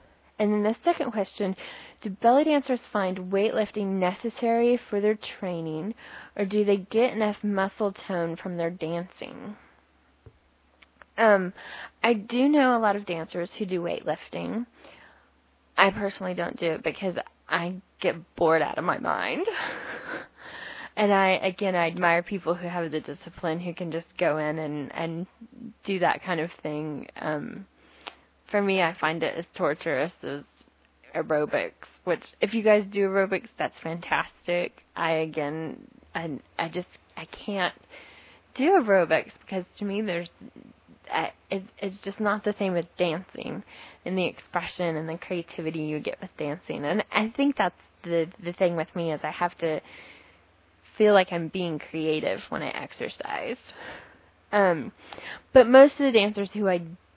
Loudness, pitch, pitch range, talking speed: -27 LUFS, 185 Hz, 165-210 Hz, 155 wpm